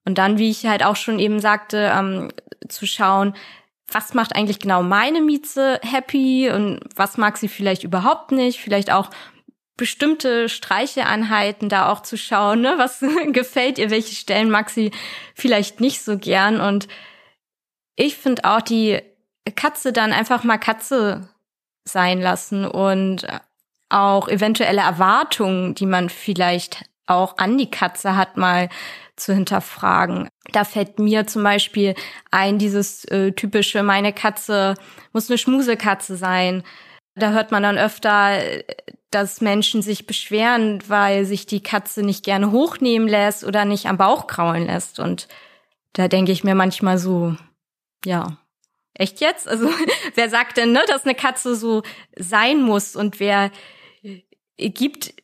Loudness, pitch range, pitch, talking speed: -19 LUFS, 195-230 Hz, 210 Hz, 145 wpm